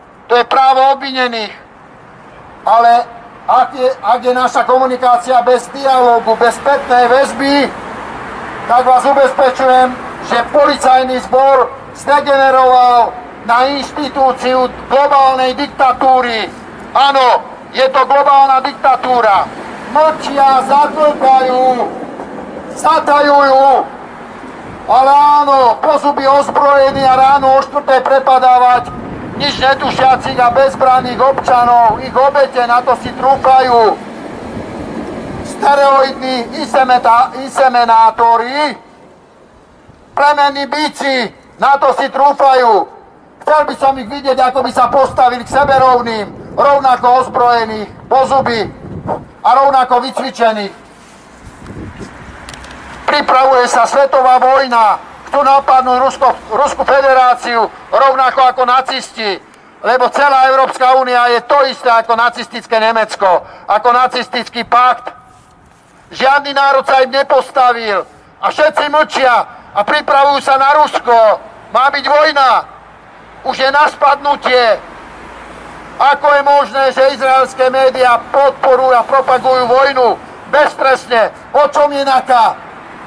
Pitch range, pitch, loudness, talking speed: 245-280 Hz, 265 Hz, -10 LUFS, 100 wpm